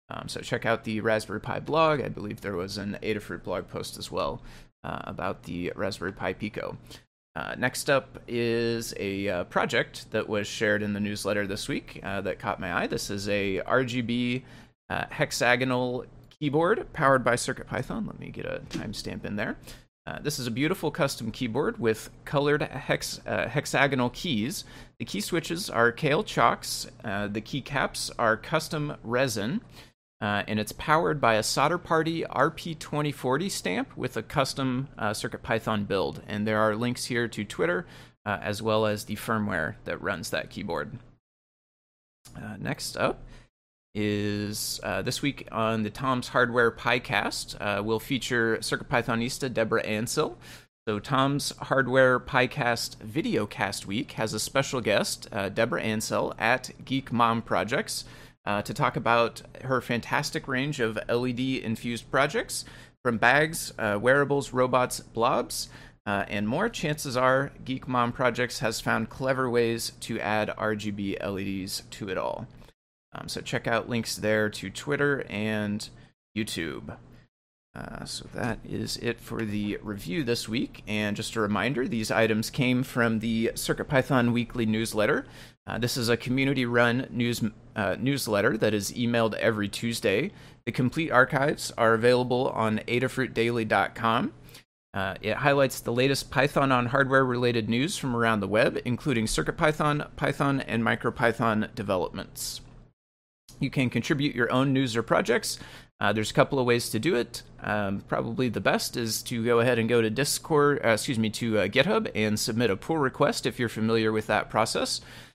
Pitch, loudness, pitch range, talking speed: 120 Hz, -27 LUFS, 110-130 Hz, 160 wpm